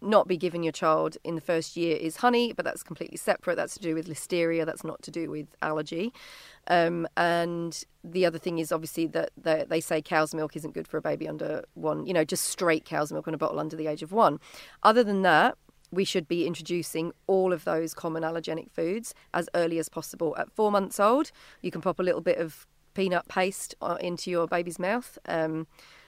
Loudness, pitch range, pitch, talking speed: -28 LUFS, 160-180 Hz, 170 Hz, 215 wpm